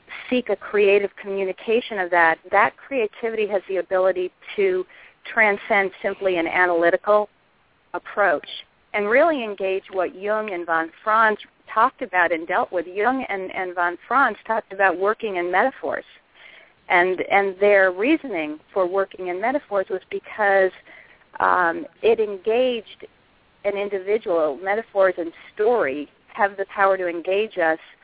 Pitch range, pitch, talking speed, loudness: 185-225 Hz, 200 Hz, 135 wpm, -21 LUFS